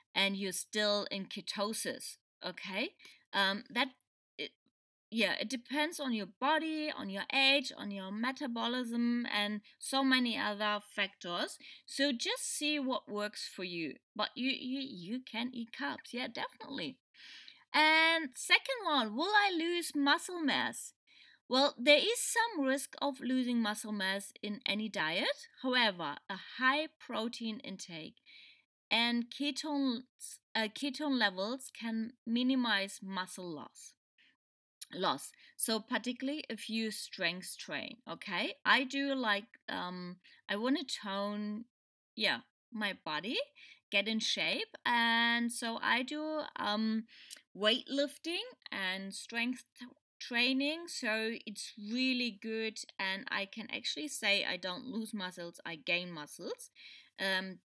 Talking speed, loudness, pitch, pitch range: 130 wpm, -34 LUFS, 235 Hz, 205-285 Hz